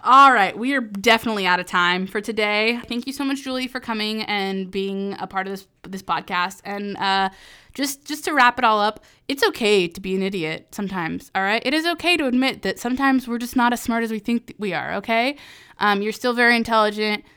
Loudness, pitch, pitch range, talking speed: -21 LUFS, 220 Hz, 195-245 Hz, 230 wpm